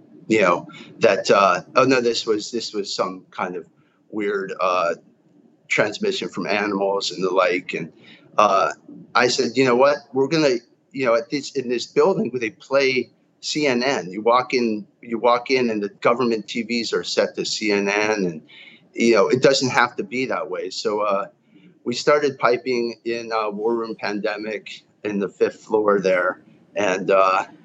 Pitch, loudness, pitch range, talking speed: 120 Hz, -21 LUFS, 105-130 Hz, 180 wpm